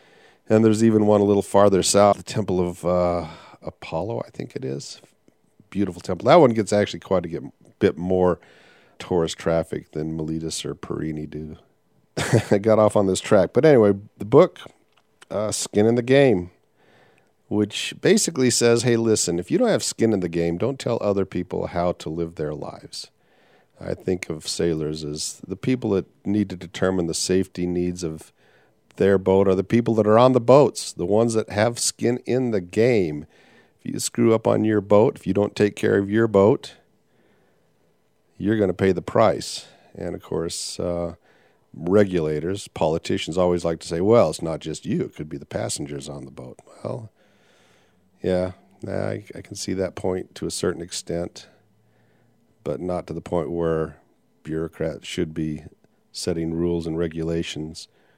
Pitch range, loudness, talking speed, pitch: 85-105 Hz, -22 LUFS, 175 wpm, 95 Hz